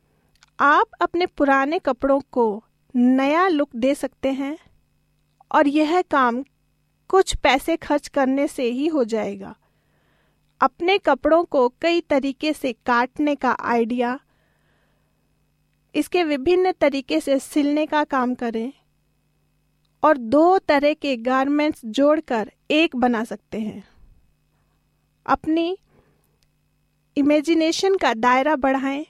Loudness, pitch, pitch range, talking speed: -20 LUFS, 285 Hz, 255-310 Hz, 110 wpm